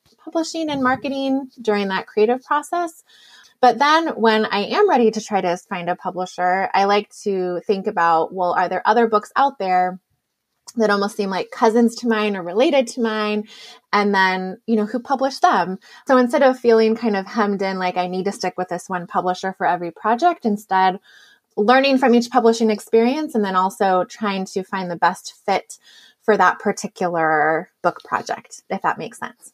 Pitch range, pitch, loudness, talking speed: 185-245 Hz, 210 Hz, -19 LUFS, 190 wpm